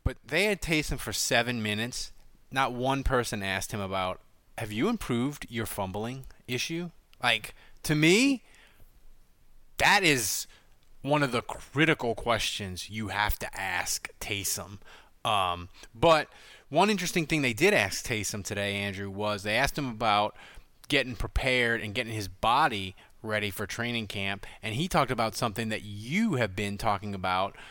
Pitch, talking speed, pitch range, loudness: 115 Hz, 155 wpm, 100-135 Hz, -28 LUFS